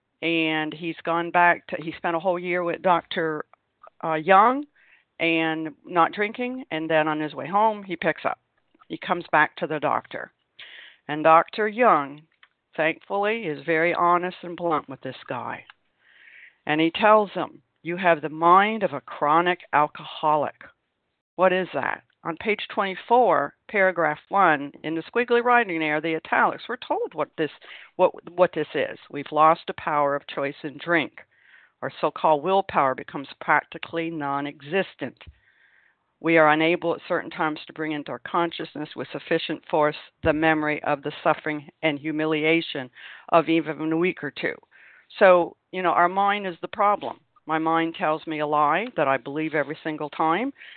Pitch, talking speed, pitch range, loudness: 165 Hz, 170 wpm, 155-180 Hz, -23 LUFS